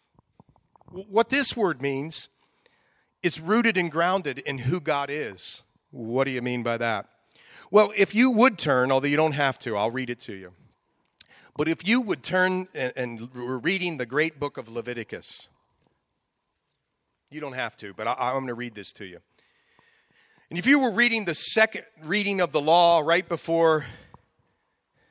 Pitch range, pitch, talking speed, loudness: 130-195 Hz, 160 Hz, 175 wpm, -24 LUFS